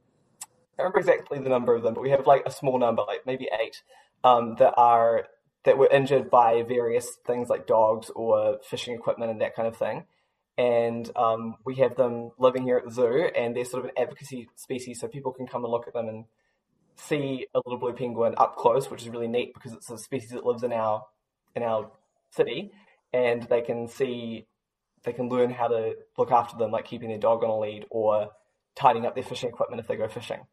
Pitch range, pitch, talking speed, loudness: 115-180 Hz, 125 Hz, 220 wpm, -26 LUFS